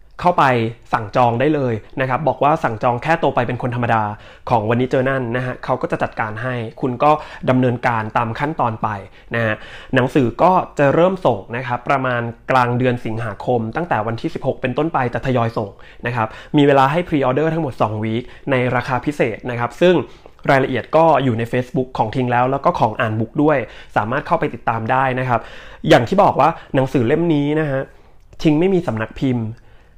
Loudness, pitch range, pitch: -18 LUFS, 115-145 Hz, 125 Hz